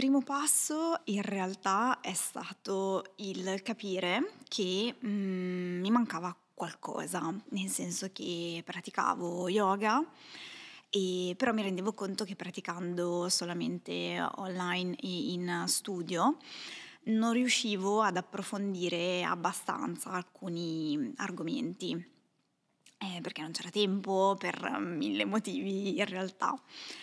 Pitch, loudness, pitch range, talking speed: 195 Hz, -33 LUFS, 180-220 Hz, 105 wpm